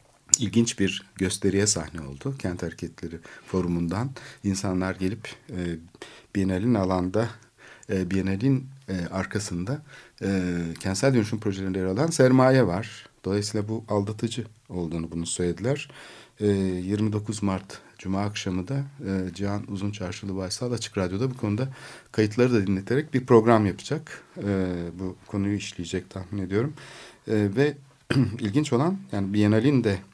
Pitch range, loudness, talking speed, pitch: 95-120 Hz, -26 LUFS, 130 wpm, 100 Hz